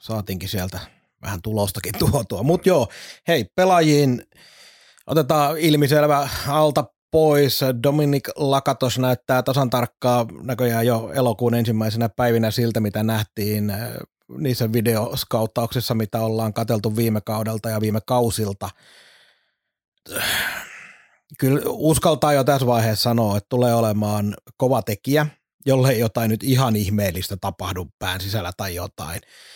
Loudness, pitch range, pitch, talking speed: -21 LUFS, 110-135 Hz, 120 Hz, 115 wpm